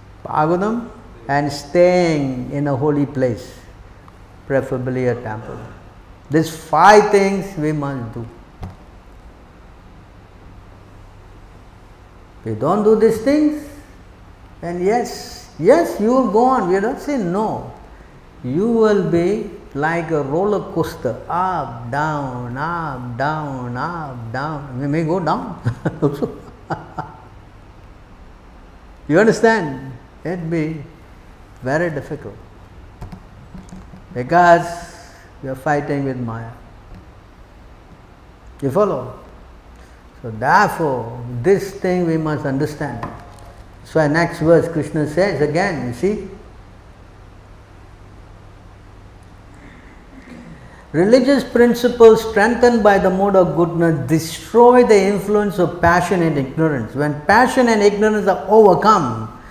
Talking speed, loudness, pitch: 100 wpm, -17 LUFS, 145 Hz